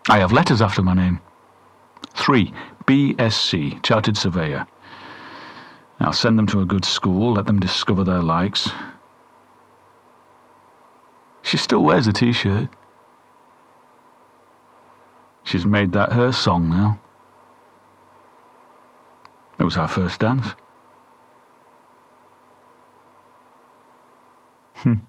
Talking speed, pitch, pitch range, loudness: 95 wpm, 100 Hz, 95-115 Hz, -19 LUFS